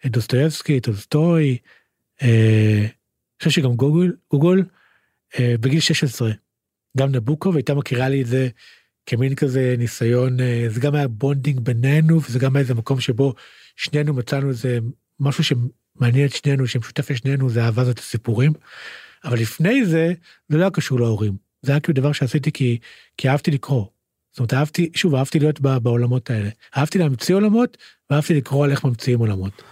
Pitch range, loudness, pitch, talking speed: 120-150 Hz, -20 LUFS, 135 Hz, 165 wpm